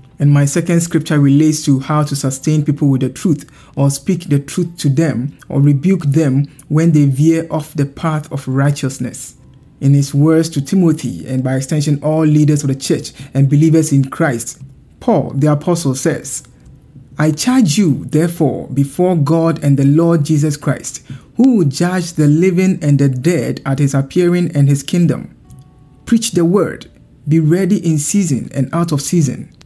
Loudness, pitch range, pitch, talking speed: -14 LUFS, 140-165 Hz, 150 Hz, 175 wpm